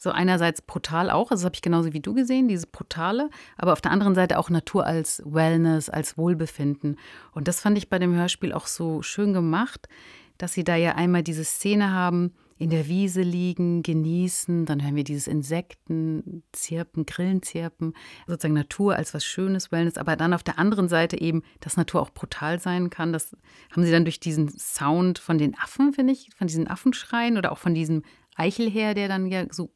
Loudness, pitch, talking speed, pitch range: -25 LUFS, 170 Hz, 205 wpm, 160-185 Hz